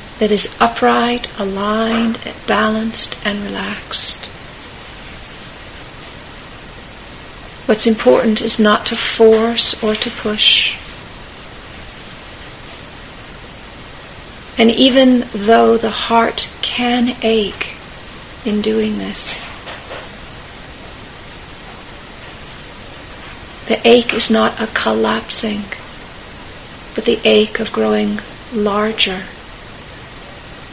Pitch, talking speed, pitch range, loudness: 225 Hz, 75 wpm, 210-230 Hz, -13 LUFS